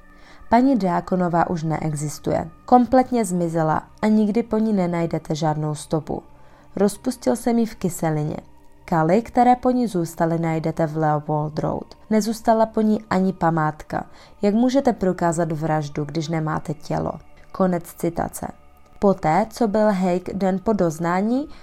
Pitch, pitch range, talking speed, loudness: 180 Hz, 160-220 Hz, 135 wpm, -21 LUFS